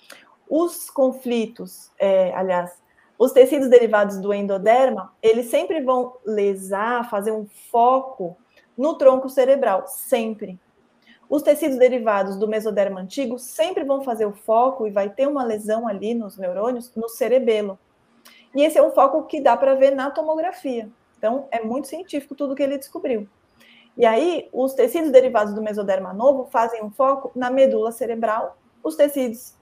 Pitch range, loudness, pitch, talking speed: 215-275 Hz, -20 LUFS, 245 Hz, 155 wpm